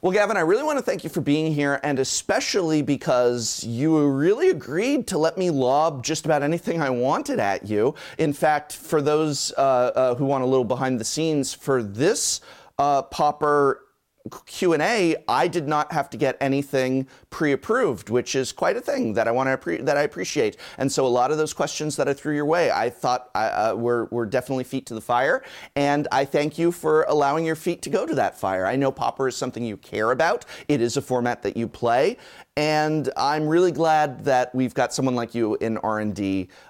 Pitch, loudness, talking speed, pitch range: 140 Hz, -23 LUFS, 210 wpm, 125-155 Hz